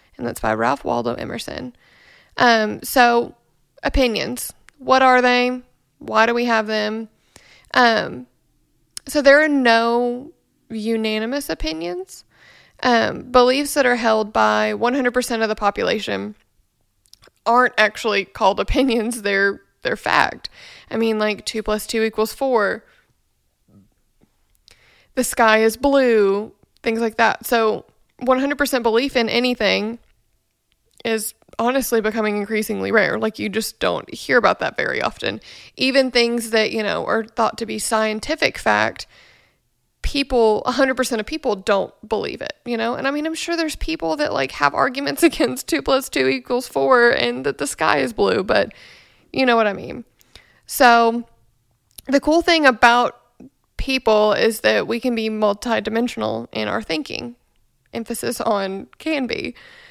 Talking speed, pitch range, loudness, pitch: 145 wpm, 210-255 Hz, -19 LUFS, 230 Hz